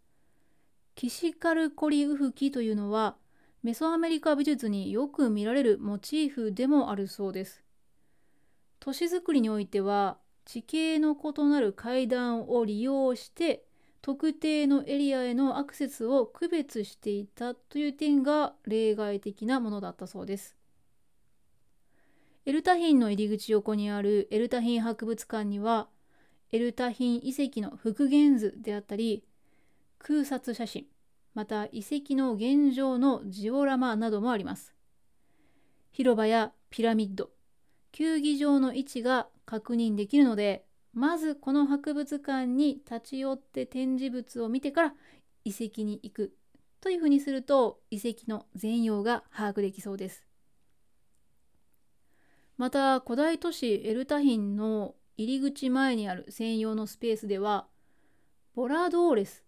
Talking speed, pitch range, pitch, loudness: 270 characters per minute, 215-280 Hz, 245 Hz, -29 LUFS